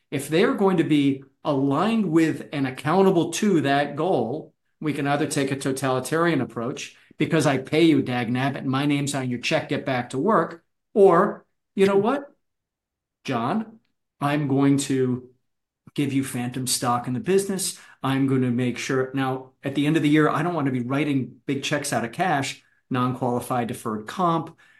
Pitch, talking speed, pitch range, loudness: 140 Hz, 185 wpm, 130-165 Hz, -23 LUFS